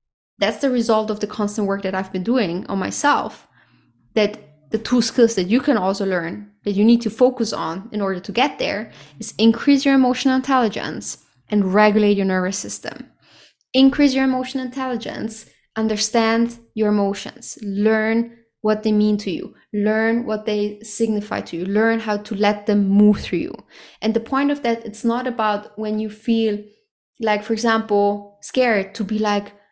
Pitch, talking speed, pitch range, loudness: 215 Hz, 180 wpm, 205-235 Hz, -20 LUFS